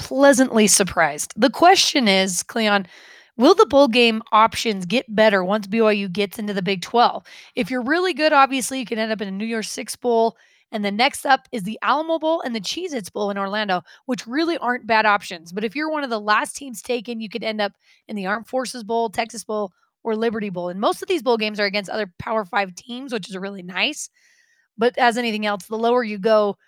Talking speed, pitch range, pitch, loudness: 230 wpm, 205-260 Hz, 225 Hz, -20 LUFS